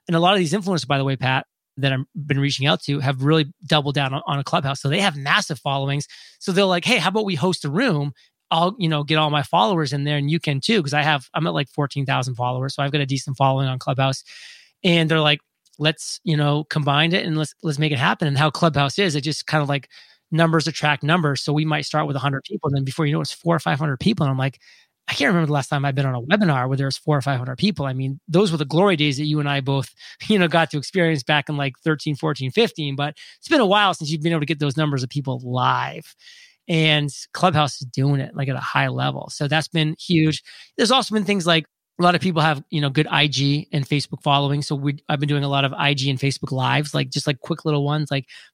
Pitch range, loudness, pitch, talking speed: 140-165 Hz, -21 LUFS, 150 Hz, 275 wpm